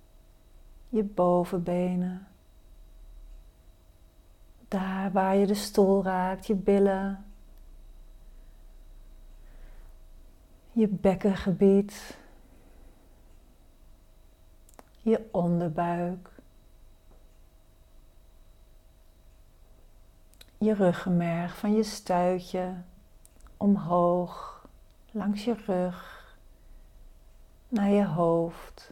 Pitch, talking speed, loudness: 165 Hz, 55 wpm, -27 LUFS